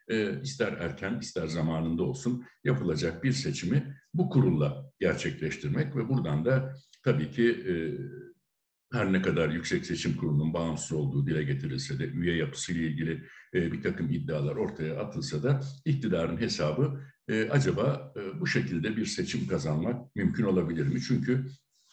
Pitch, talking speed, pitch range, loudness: 125 Hz, 145 wpm, 80-140 Hz, -30 LUFS